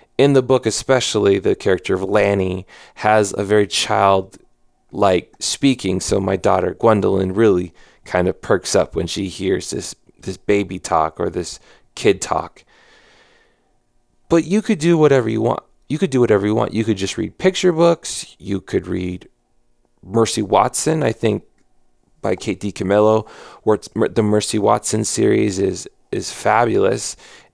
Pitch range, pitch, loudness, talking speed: 95-120 Hz, 105 Hz, -18 LUFS, 155 wpm